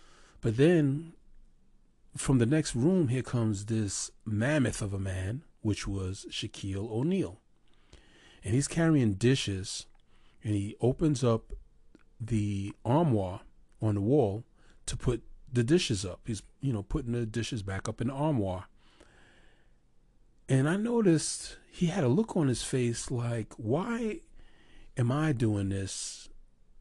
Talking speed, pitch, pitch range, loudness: 140 wpm, 115 Hz, 105-145 Hz, -30 LUFS